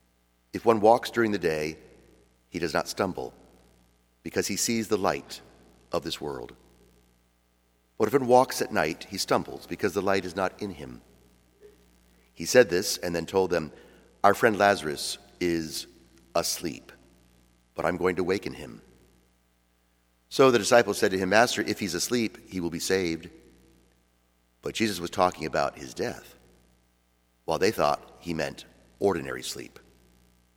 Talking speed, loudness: 155 wpm, -27 LUFS